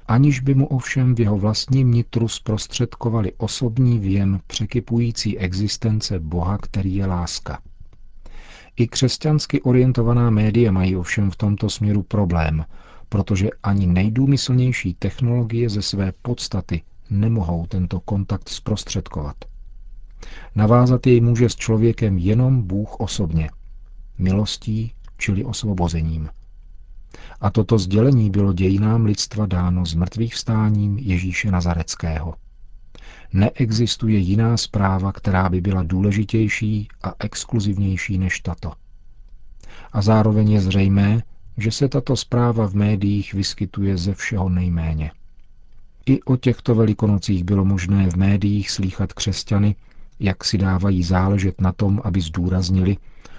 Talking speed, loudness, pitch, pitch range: 115 wpm, -20 LUFS, 100 Hz, 95-115 Hz